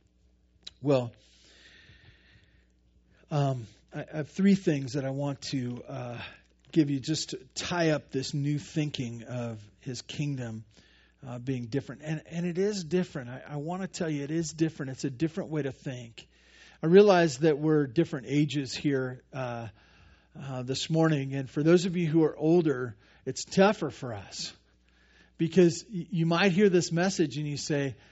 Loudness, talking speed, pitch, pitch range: -29 LUFS, 165 wpm, 145 Hz, 125-165 Hz